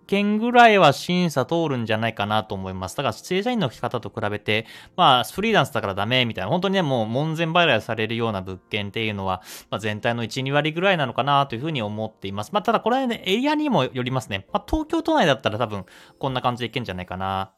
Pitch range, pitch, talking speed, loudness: 110-175 Hz, 125 Hz, 500 characters per minute, -22 LUFS